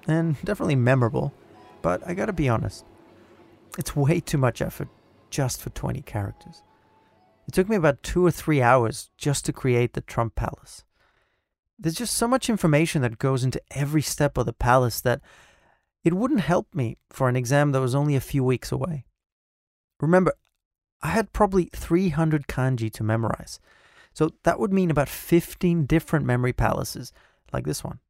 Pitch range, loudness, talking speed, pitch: 120-170 Hz, -24 LUFS, 170 wpm, 140 Hz